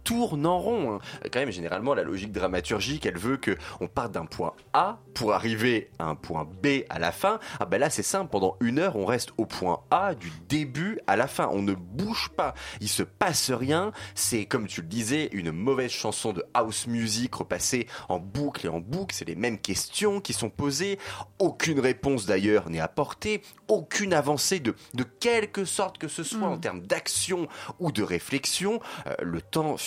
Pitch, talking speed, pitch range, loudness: 125 Hz, 200 wpm, 100-155 Hz, -28 LUFS